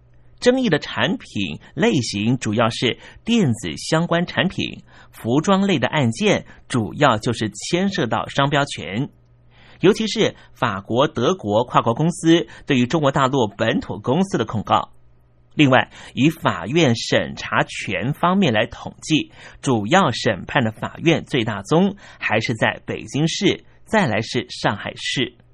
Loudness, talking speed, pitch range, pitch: -20 LUFS, 215 characters per minute, 115-170 Hz, 140 Hz